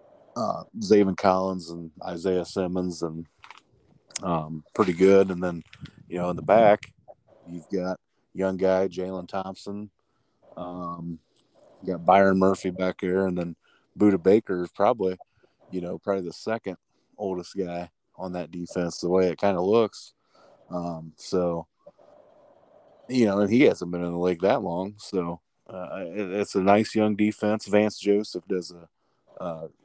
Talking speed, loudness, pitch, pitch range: 155 wpm, -25 LUFS, 95 Hz, 85-100 Hz